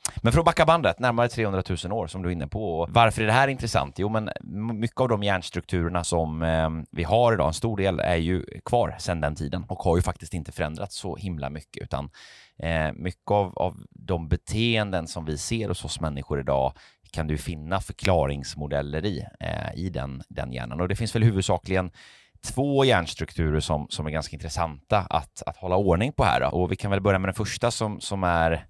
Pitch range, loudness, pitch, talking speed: 80-105 Hz, -26 LUFS, 90 Hz, 215 wpm